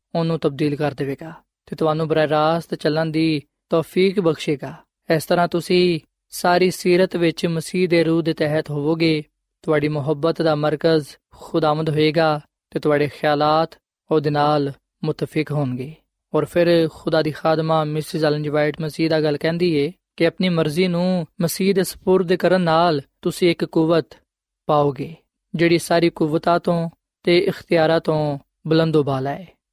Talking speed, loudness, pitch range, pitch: 150 wpm, -20 LUFS, 150-170 Hz, 160 Hz